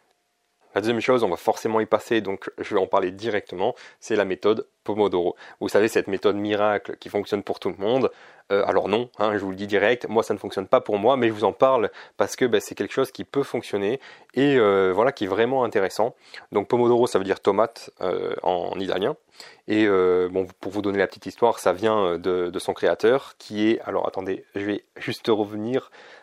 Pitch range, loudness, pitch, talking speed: 100-120 Hz, -23 LUFS, 105 Hz, 225 wpm